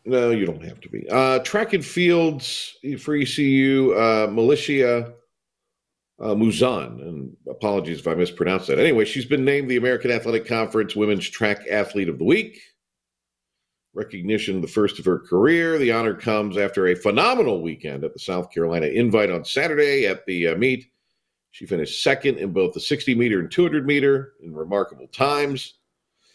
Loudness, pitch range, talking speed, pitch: -21 LUFS, 105-140 Hz, 170 wpm, 120 Hz